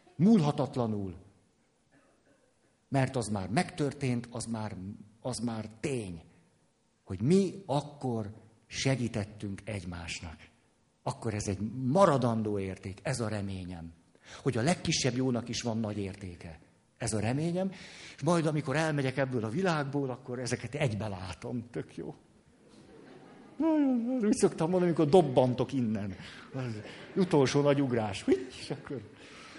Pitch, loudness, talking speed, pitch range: 120 Hz, -31 LUFS, 120 wpm, 105-145 Hz